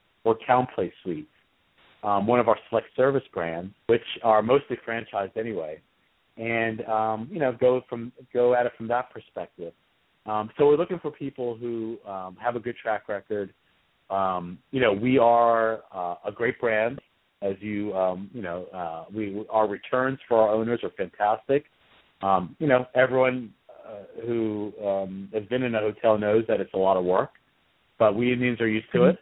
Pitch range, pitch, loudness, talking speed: 105-125 Hz, 115 Hz, -25 LUFS, 185 wpm